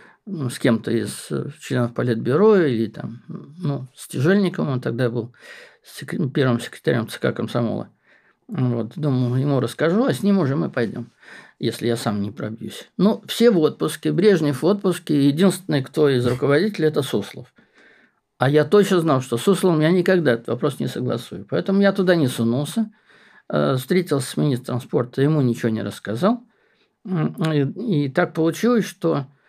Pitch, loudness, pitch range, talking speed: 145 Hz, -21 LUFS, 125-185 Hz, 155 wpm